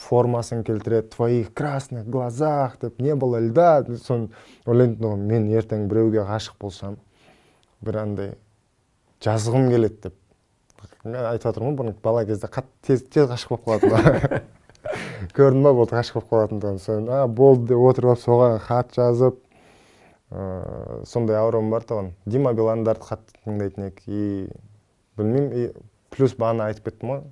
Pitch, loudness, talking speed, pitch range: 115 Hz, -21 LUFS, 150 wpm, 110-125 Hz